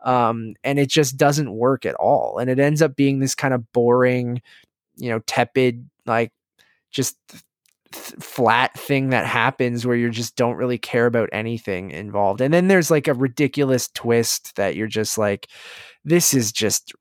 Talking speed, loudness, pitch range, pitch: 175 wpm, -20 LUFS, 115-135 Hz, 125 Hz